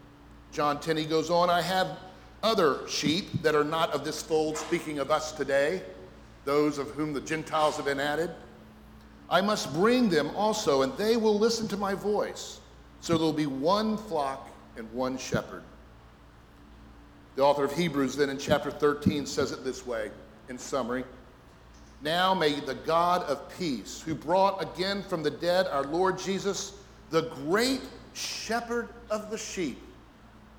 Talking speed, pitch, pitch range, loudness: 165 wpm, 155 Hz, 140-190 Hz, -28 LUFS